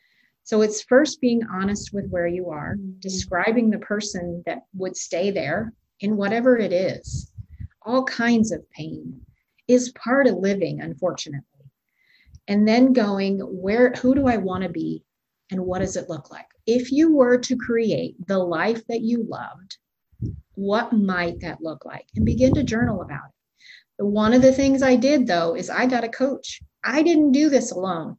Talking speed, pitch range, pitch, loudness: 175 wpm, 185-250 Hz, 215 Hz, -21 LUFS